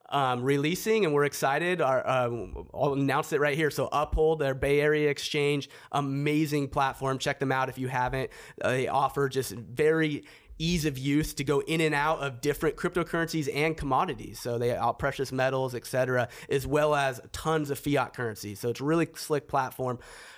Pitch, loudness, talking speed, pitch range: 140 Hz, -28 LUFS, 185 wpm, 130-150 Hz